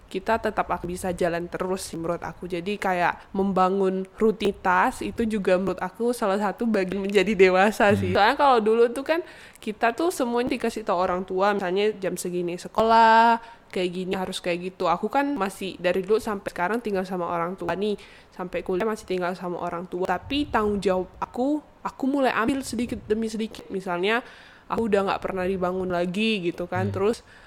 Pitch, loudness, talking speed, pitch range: 195 Hz, -24 LUFS, 180 wpm, 185-225 Hz